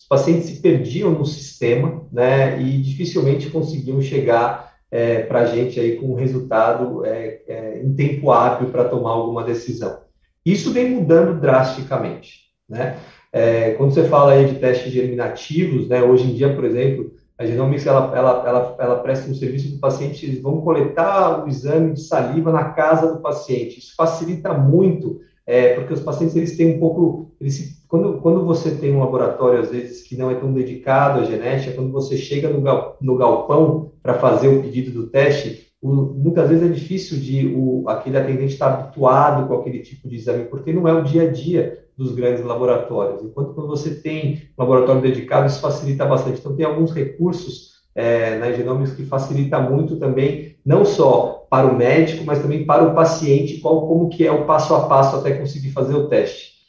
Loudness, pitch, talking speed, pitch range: -18 LUFS, 140 Hz, 195 wpm, 130-160 Hz